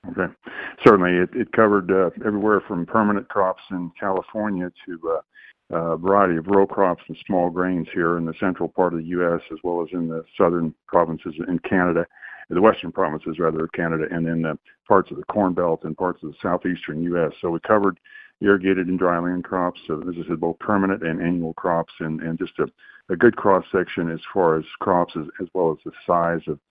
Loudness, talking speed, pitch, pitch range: -22 LUFS, 210 wpm, 85 Hz, 85-95 Hz